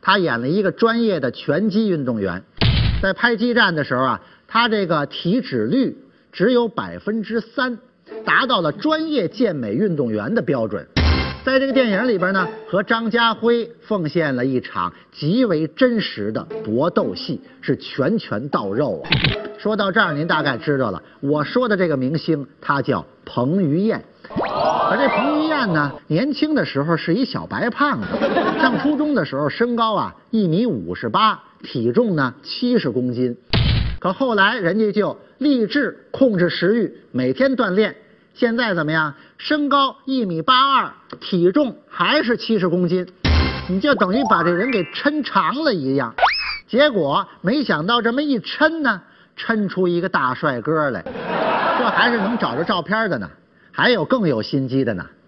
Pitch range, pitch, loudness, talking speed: 160-245 Hz, 210 Hz, -19 LUFS, 240 characters per minute